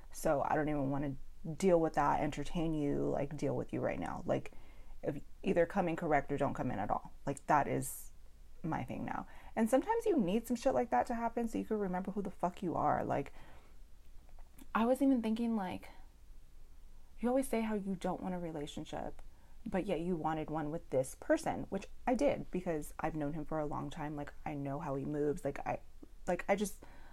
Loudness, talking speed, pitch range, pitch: -36 LUFS, 220 wpm, 135-200 Hz, 155 Hz